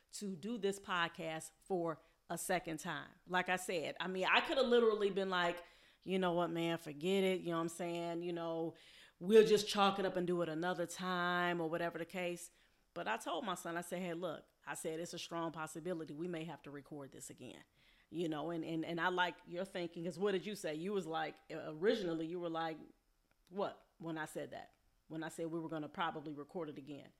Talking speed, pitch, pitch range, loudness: 230 wpm, 170 Hz, 165-180 Hz, -39 LUFS